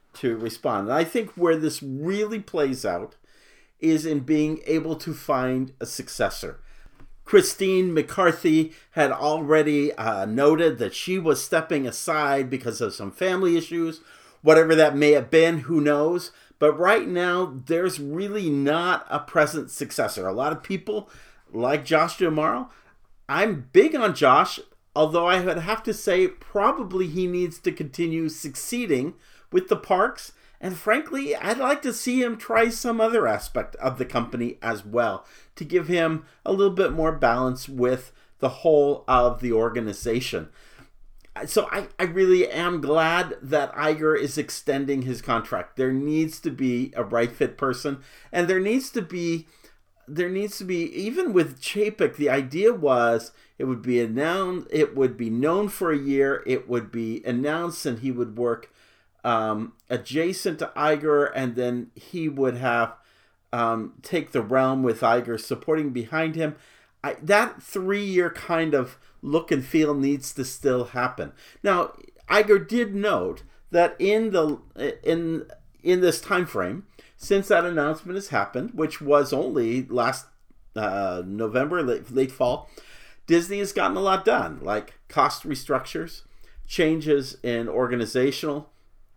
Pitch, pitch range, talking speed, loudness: 155 Hz, 130-180 Hz, 155 wpm, -24 LUFS